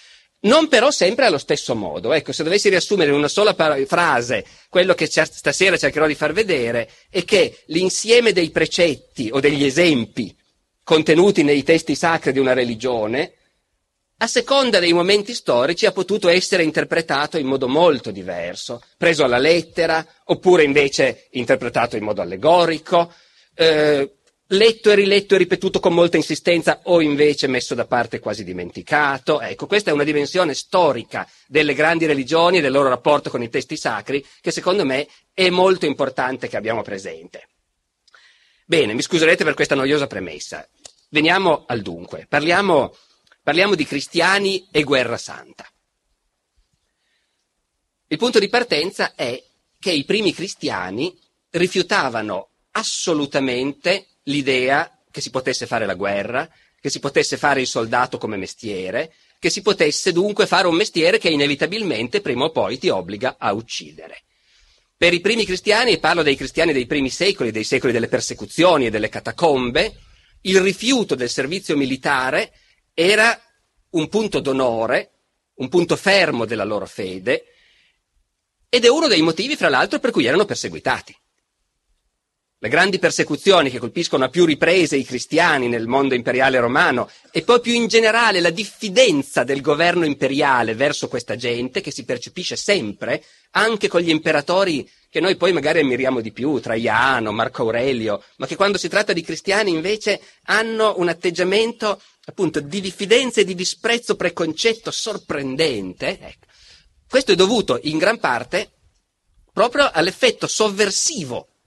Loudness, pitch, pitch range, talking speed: -18 LUFS, 170 Hz, 145-200 Hz, 150 wpm